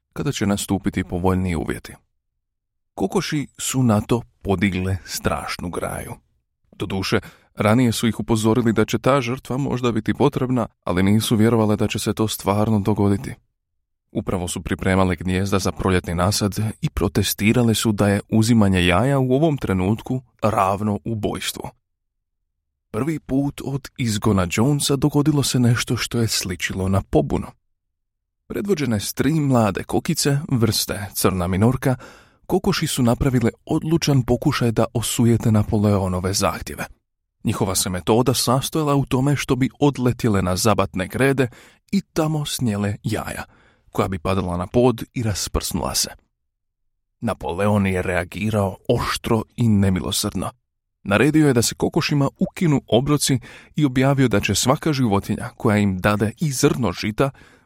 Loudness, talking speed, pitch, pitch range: -20 LUFS, 135 wpm, 110 Hz, 100-130 Hz